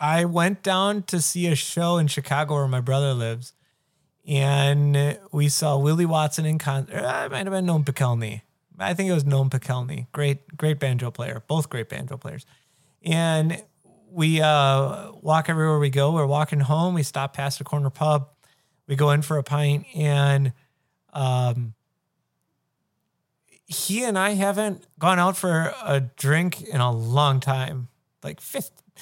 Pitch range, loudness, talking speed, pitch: 135-160 Hz, -23 LUFS, 165 wpm, 145 Hz